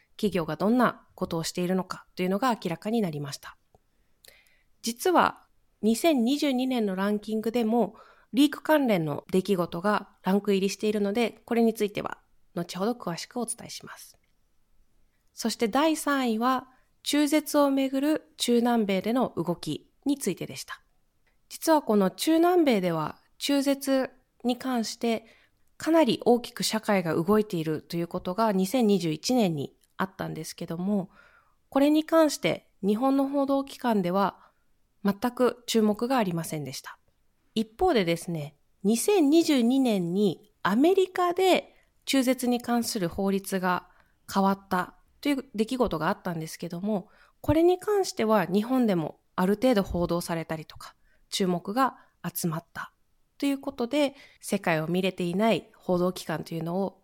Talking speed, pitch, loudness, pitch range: 290 characters per minute, 215 Hz, -27 LUFS, 185-260 Hz